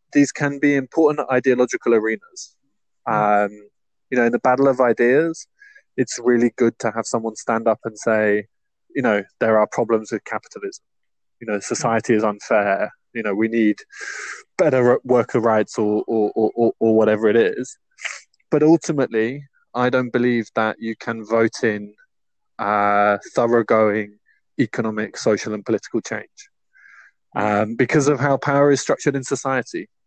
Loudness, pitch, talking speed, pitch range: -19 LUFS, 115 Hz, 150 wpm, 110-130 Hz